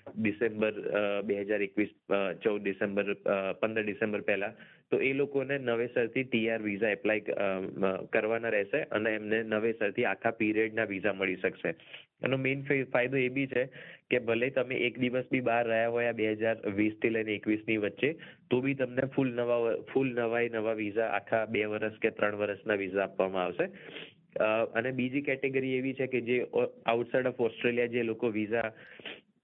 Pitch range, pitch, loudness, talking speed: 105-125 Hz, 115 Hz, -31 LUFS, 165 wpm